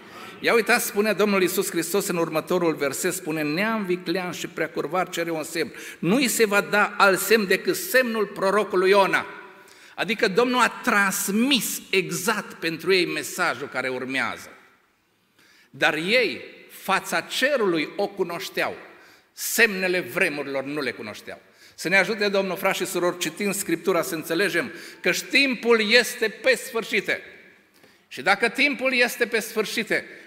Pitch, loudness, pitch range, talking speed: 200 Hz, -22 LUFS, 175-230 Hz, 140 wpm